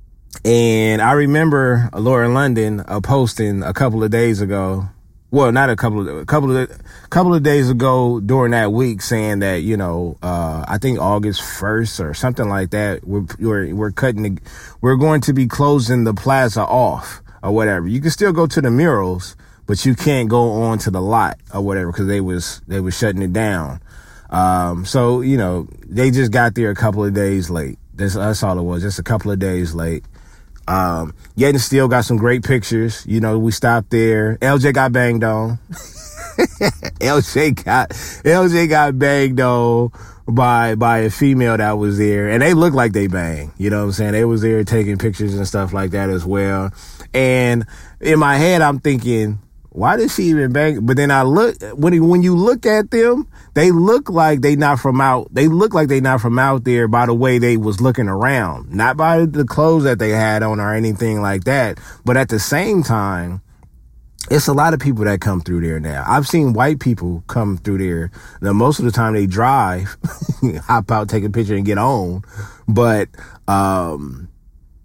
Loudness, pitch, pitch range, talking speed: -16 LUFS, 110 Hz, 100-130 Hz, 205 wpm